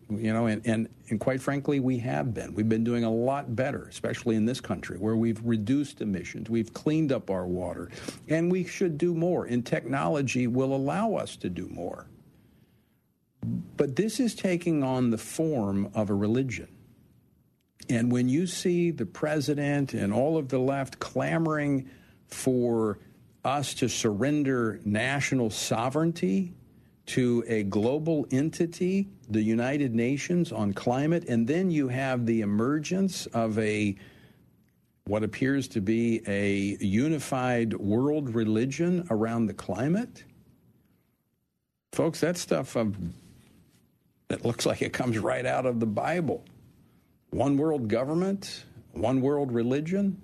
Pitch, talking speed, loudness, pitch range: 125 Hz, 140 wpm, -28 LUFS, 110-150 Hz